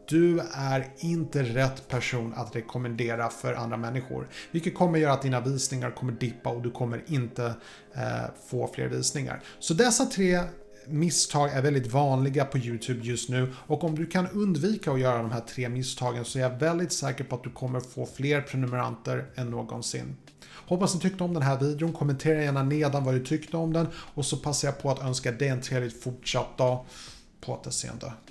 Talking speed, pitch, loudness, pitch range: 195 wpm, 135 Hz, -29 LUFS, 125-155 Hz